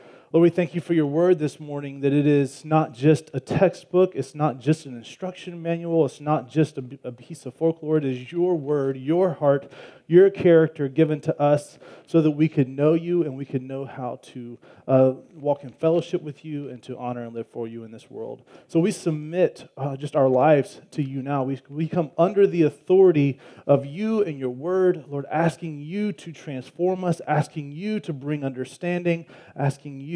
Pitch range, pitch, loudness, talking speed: 135-170 Hz, 150 Hz, -23 LUFS, 205 wpm